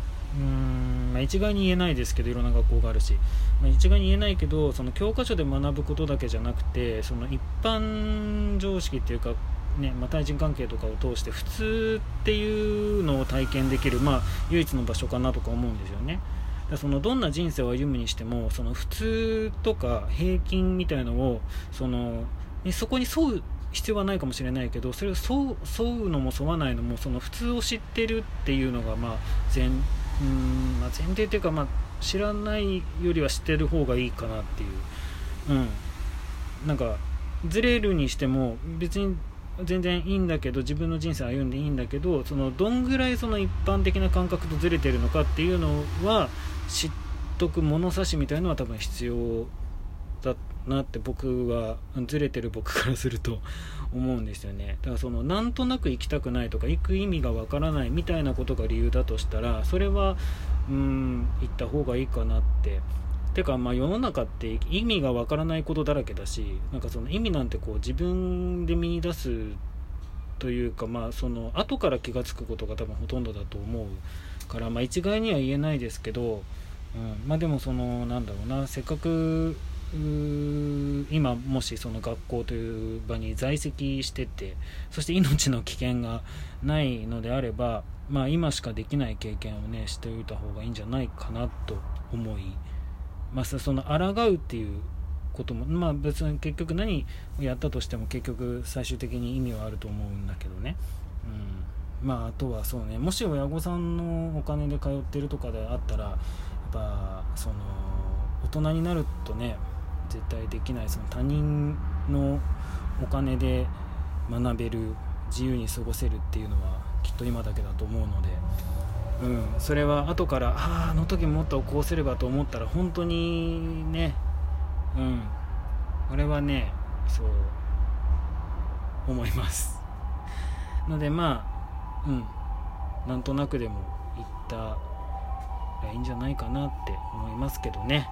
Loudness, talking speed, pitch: -29 LUFS, 335 characters per minute, 110 Hz